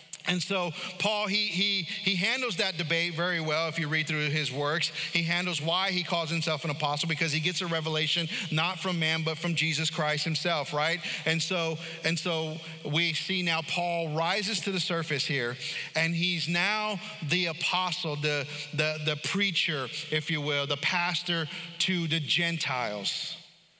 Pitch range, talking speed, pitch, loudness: 155-180 Hz, 175 wpm, 165 Hz, -28 LUFS